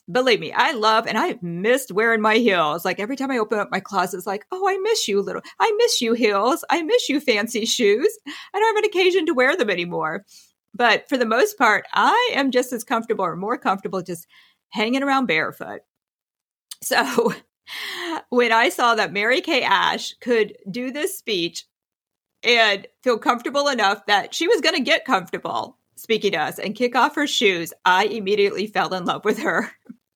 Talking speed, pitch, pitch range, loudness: 195 wpm, 240 Hz, 210-305 Hz, -20 LUFS